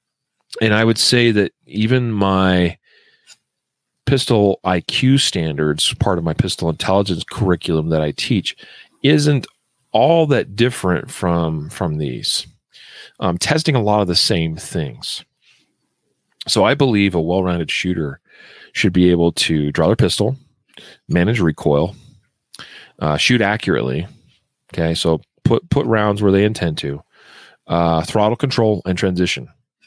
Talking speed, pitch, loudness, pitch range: 135 wpm, 95 Hz, -17 LUFS, 85-115 Hz